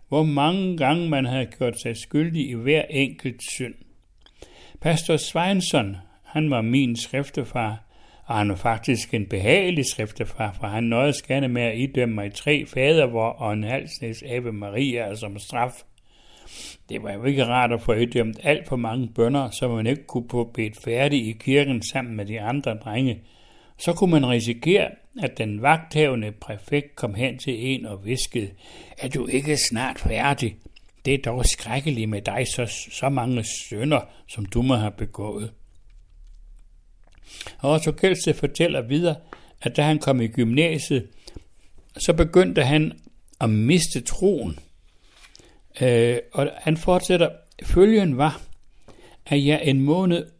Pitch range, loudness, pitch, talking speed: 115-145 Hz, -23 LUFS, 125 Hz, 155 wpm